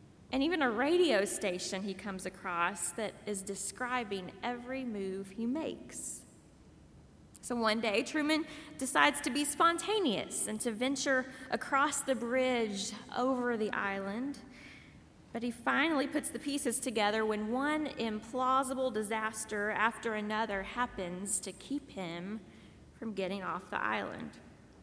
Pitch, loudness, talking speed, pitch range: 235 Hz, -34 LUFS, 130 wpm, 205-265 Hz